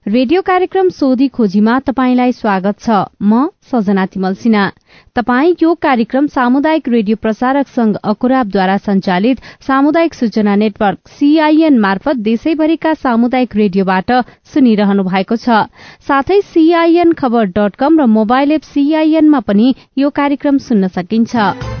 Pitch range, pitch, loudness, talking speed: 210-290 Hz, 250 Hz, -12 LUFS, 125 wpm